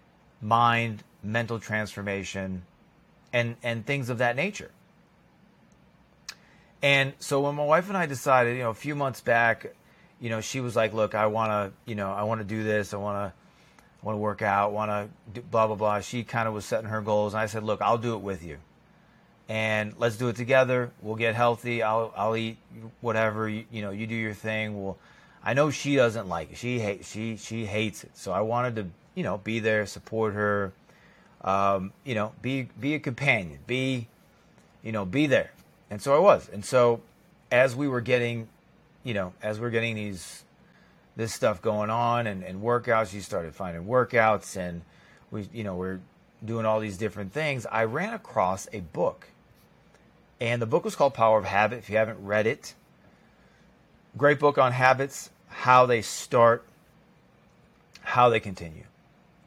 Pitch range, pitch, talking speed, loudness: 105-120 Hz, 110 Hz, 185 wpm, -27 LUFS